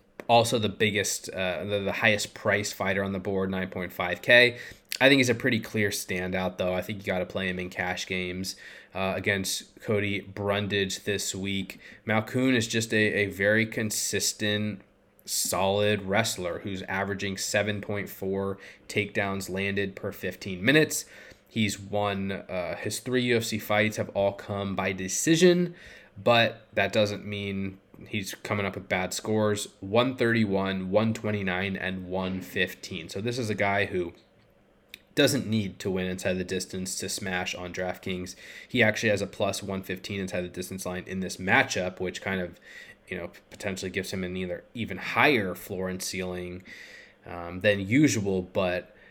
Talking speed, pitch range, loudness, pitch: 160 wpm, 95-105 Hz, -27 LUFS, 100 Hz